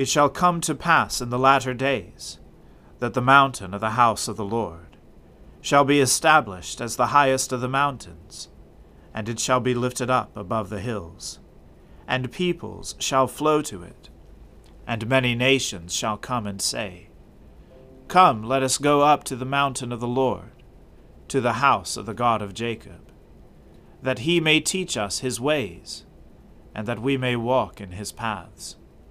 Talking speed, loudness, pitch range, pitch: 170 wpm, -22 LUFS, 100-135 Hz, 125 Hz